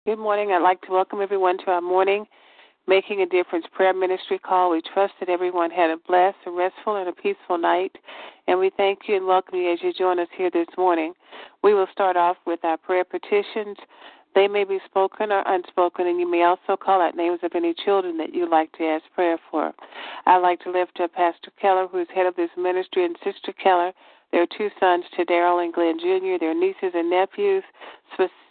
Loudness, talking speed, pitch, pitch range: -22 LUFS, 215 wpm, 185 Hz, 175-195 Hz